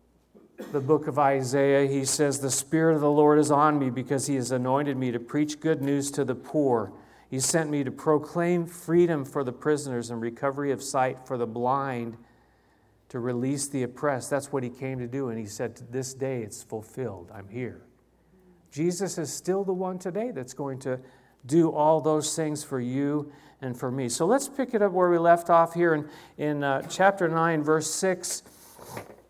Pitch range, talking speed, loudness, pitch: 130-160 Hz, 200 wpm, -26 LUFS, 140 Hz